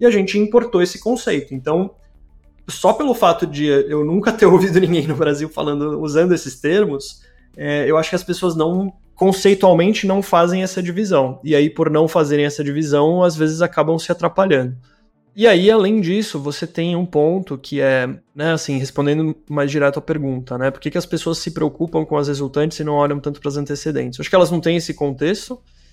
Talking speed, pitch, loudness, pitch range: 205 wpm, 155 Hz, -17 LUFS, 145-180 Hz